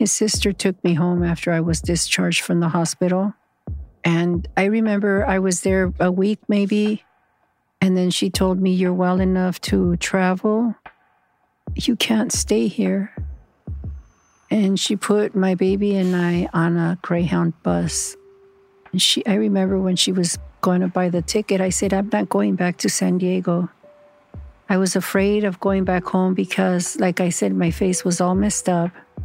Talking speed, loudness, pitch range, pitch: 170 wpm, -20 LUFS, 175-200 Hz, 185 Hz